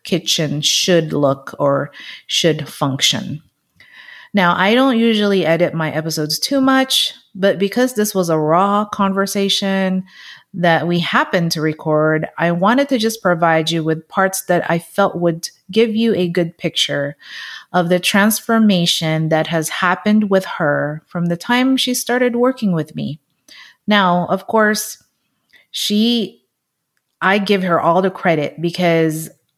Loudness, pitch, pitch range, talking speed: -16 LUFS, 180 Hz, 160-210 Hz, 145 wpm